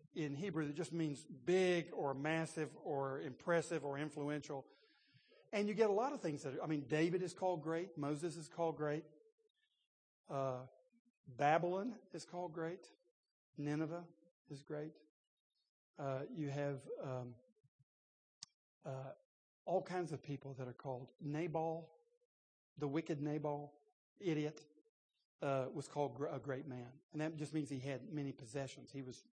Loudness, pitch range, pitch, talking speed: -43 LUFS, 140-170 Hz, 150 Hz, 145 wpm